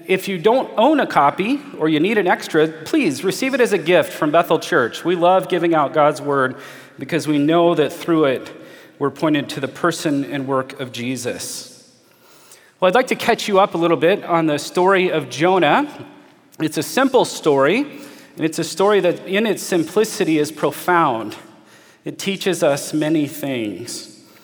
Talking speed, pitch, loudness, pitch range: 185 wpm, 170 Hz, -18 LUFS, 150-195 Hz